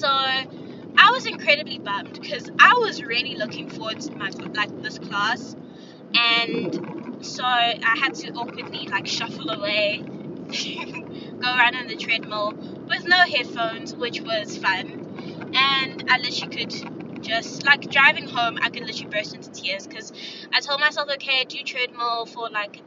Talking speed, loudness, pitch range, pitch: 150 wpm, -22 LUFS, 235-300 Hz, 270 Hz